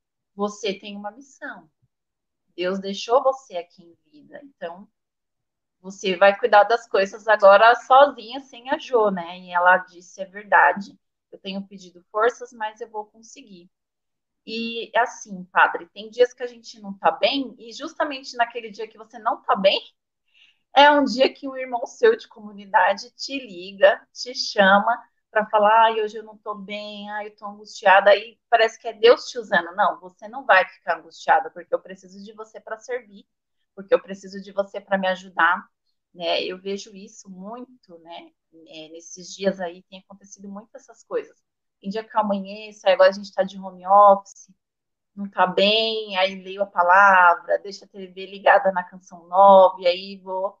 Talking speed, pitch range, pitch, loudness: 180 wpm, 190-235 Hz, 205 Hz, -20 LUFS